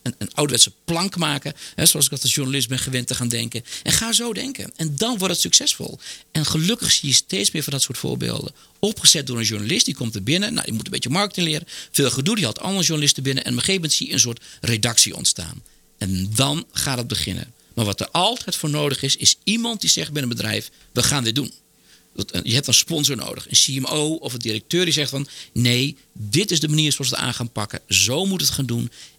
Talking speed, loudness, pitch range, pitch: 245 wpm, -19 LUFS, 120-160 Hz, 135 Hz